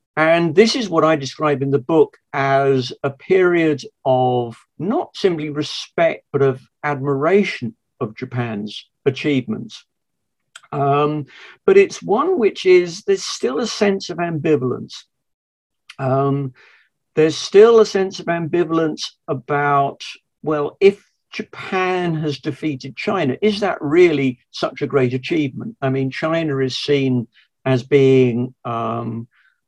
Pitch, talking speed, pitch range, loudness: 145 Hz, 125 wpm, 130-180 Hz, -18 LUFS